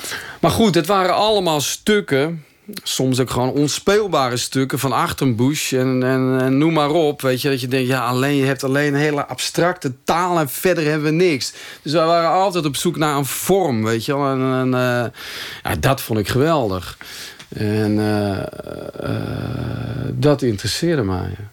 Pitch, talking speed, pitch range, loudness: 135 Hz, 165 wpm, 125-160 Hz, -18 LUFS